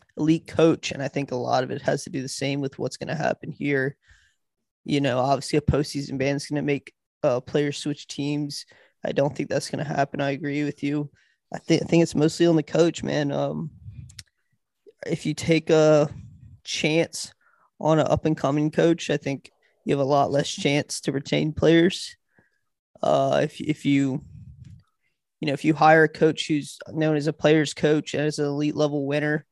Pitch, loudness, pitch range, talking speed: 145 Hz, -24 LUFS, 140-155 Hz, 205 wpm